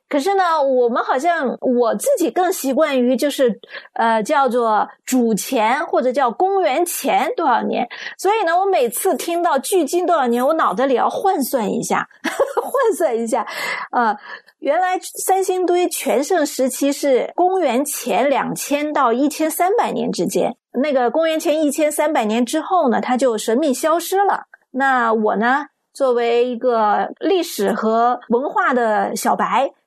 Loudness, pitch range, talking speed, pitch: -18 LUFS, 250-355 Hz, 235 characters per minute, 295 Hz